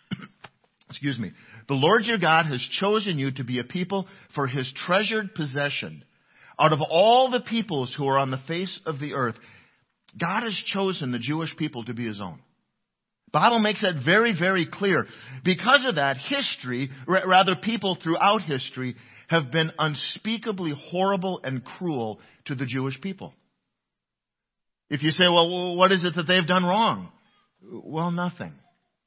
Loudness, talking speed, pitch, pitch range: -24 LUFS, 160 wpm, 165 Hz, 135-190 Hz